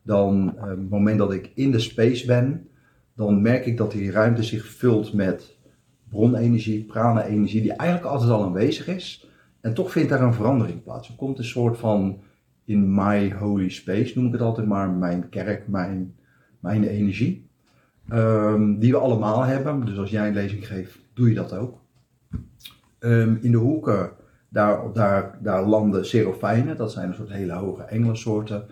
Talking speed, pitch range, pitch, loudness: 180 wpm, 100-120 Hz, 110 Hz, -22 LUFS